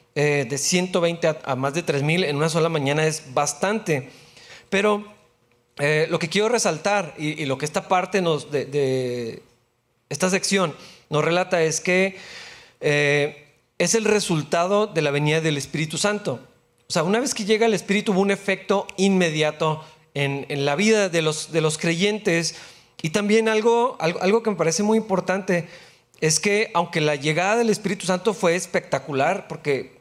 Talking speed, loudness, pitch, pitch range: 175 wpm, -22 LUFS, 170 Hz, 150-200 Hz